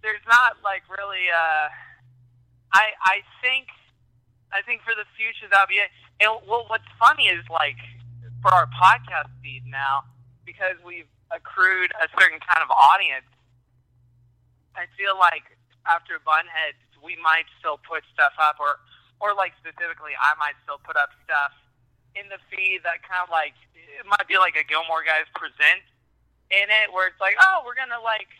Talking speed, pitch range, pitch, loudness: 170 wpm, 125-200 Hz, 165 Hz, -21 LUFS